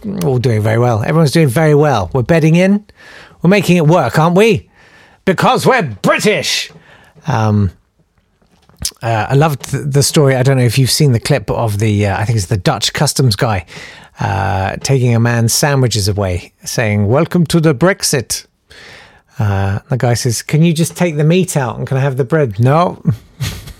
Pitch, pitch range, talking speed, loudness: 135 Hz, 115-160 Hz, 185 wpm, -13 LUFS